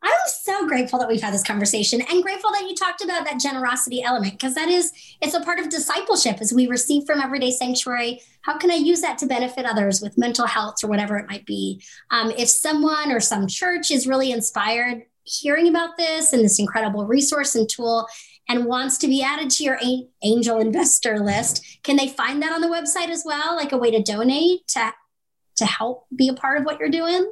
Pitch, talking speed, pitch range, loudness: 255 Hz, 215 wpm, 230-315 Hz, -20 LUFS